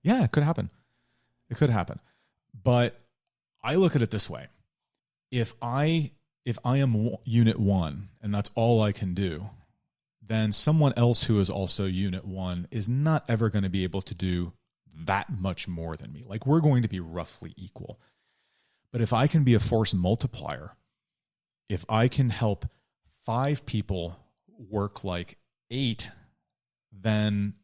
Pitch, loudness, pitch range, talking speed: 110 Hz, -27 LUFS, 100-125 Hz, 160 wpm